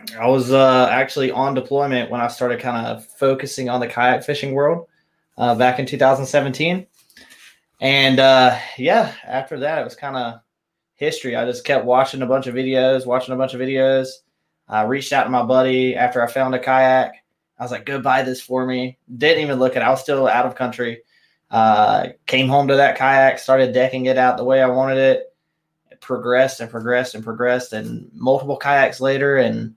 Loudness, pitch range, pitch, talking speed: -18 LUFS, 125-135 Hz, 130 Hz, 200 wpm